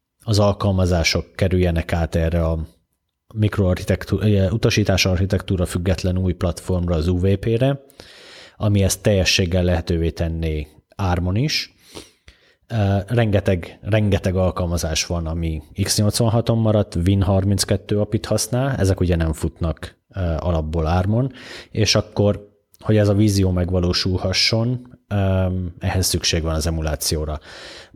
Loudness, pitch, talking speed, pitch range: -20 LUFS, 95 Hz, 105 wpm, 85-105 Hz